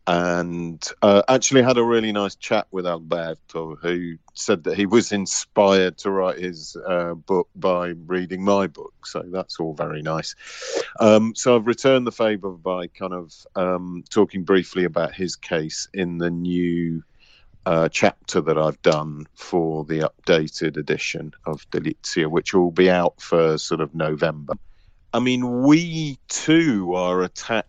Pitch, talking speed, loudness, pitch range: 90 Hz, 160 wpm, -21 LUFS, 85-100 Hz